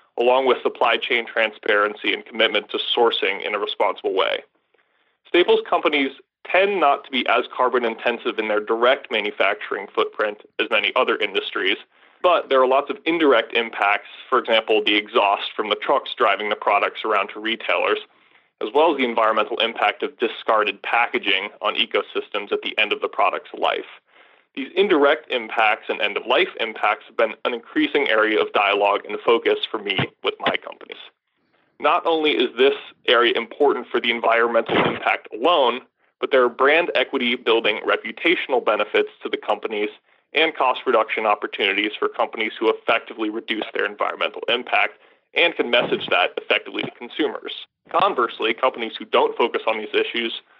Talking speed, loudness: 165 wpm, -20 LUFS